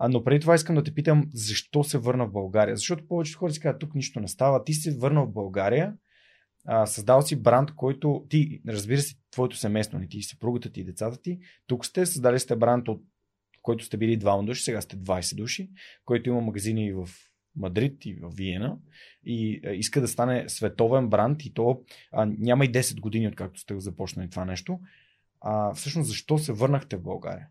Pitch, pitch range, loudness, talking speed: 120 Hz, 105-145 Hz, -26 LUFS, 200 wpm